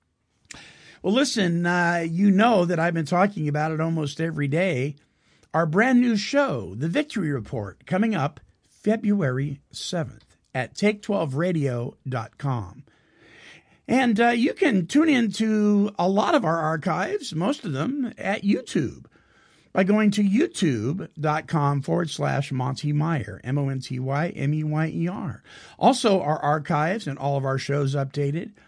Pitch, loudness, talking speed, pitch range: 165 Hz, -24 LUFS, 130 wpm, 140-205 Hz